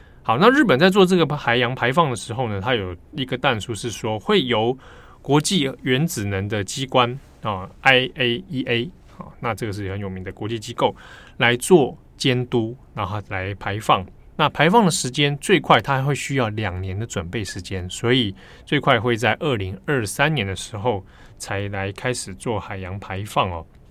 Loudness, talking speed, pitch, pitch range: -21 LUFS, 265 characters per minute, 120 Hz, 100-130 Hz